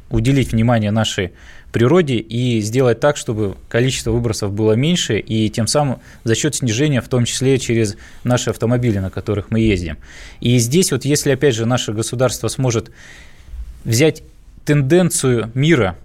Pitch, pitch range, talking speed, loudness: 120 Hz, 110-135 Hz, 150 wpm, -17 LUFS